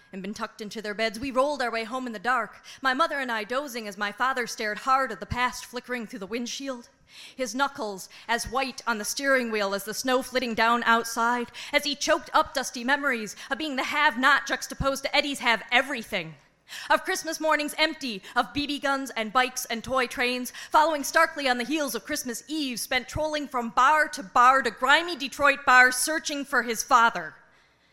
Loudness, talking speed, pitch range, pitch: -25 LUFS, 205 wpm, 230-285 Hz, 255 Hz